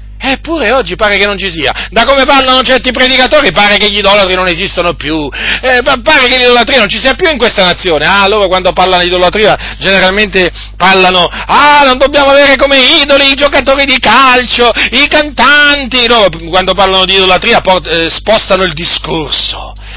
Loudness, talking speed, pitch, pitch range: -6 LUFS, 185 wpm, 215 Hz, 185-270 Hz